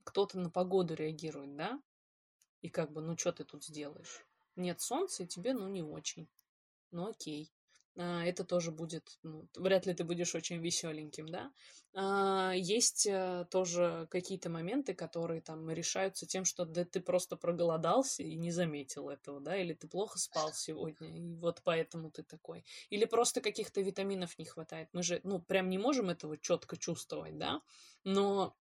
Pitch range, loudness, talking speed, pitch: 160-190 Hz, -37 LUFS, 165 wpm, 175 Hz